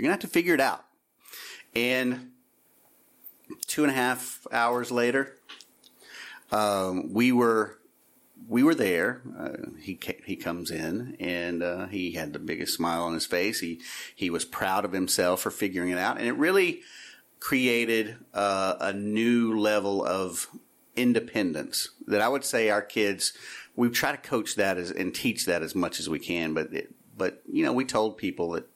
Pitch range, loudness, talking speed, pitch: 95-125 Hz, -27 LUFS, 175 wpm, 110 Hz